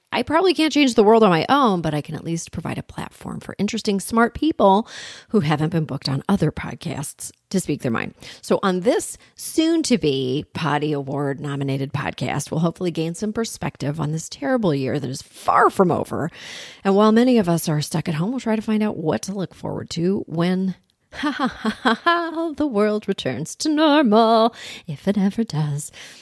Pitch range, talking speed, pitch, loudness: 150-230 Hz, 205 wpm, 190 Hz, -21 LUFS